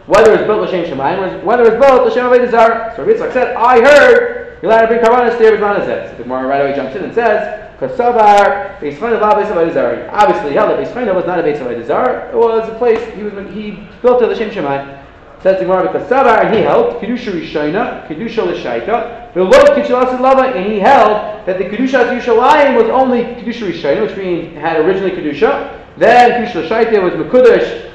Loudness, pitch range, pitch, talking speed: -11 LUFS, 200-245 Hz, 225 Hz, 200 wpm